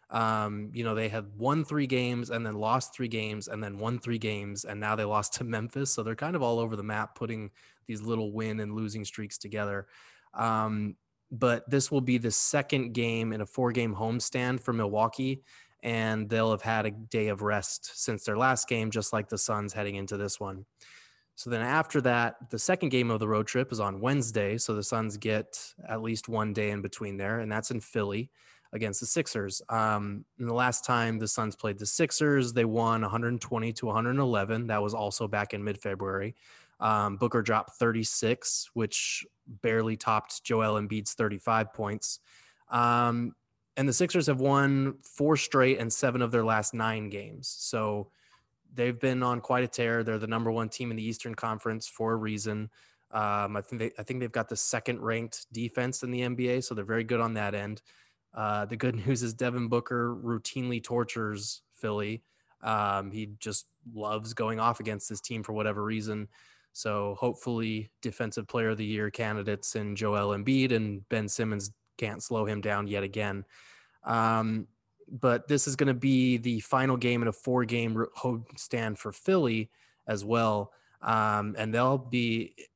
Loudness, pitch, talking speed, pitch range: -30 LUFS, 115 Hz, 190 wpm, 105-120 Hz